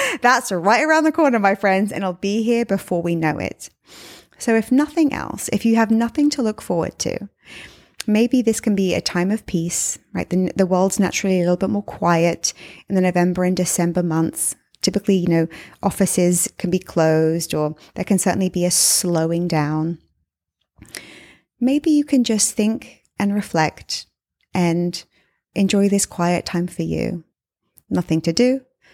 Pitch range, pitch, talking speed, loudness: 175-225 Hz, 190 Hz, 170 wpm, -19 LUFS